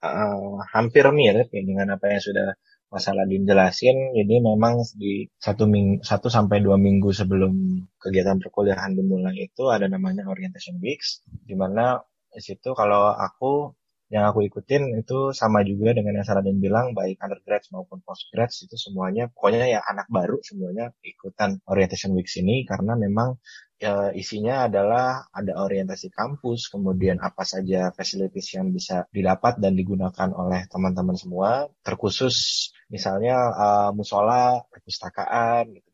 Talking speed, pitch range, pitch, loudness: 140 wpm, 95-120 Hz, 100 Hz, -23 LUFS